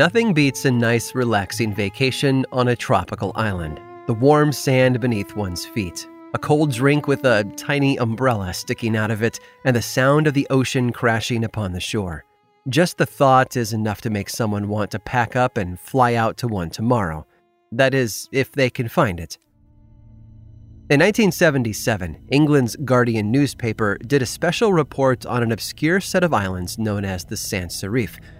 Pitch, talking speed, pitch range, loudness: 120 Hz, 175 wpm, 105-140 Hz, -20 LUFS